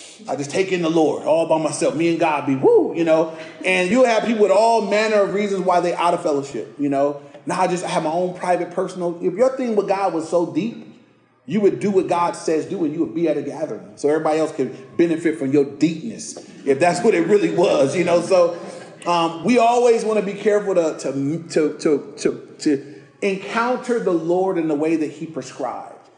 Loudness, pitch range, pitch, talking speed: -19 LUFS, 160-200 Hz, 175 Hz, 230 wpm